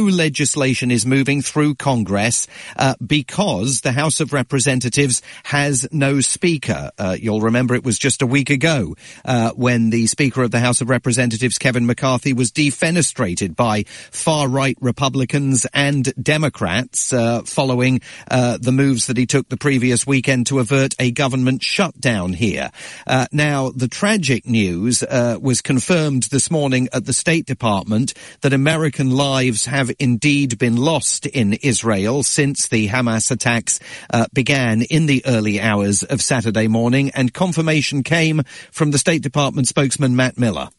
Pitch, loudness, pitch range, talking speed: 130 Hz, -17 LUFS, 120-140 Hz, 155 wpm